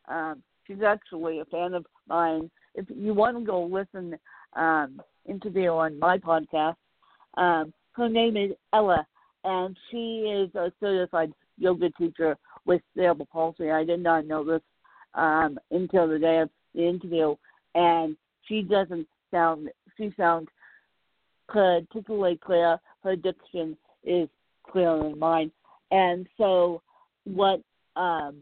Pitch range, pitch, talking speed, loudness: 160-190 Hz, 175 Hz, 135 wpm, -26 LUFS